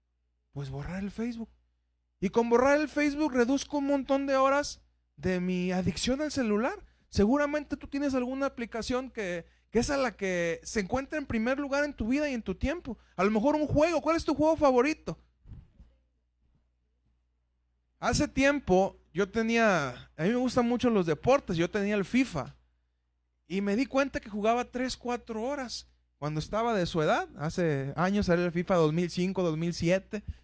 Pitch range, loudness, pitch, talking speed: 160-265 Hz, -29 LUFS, 210 Hz, 175 wpm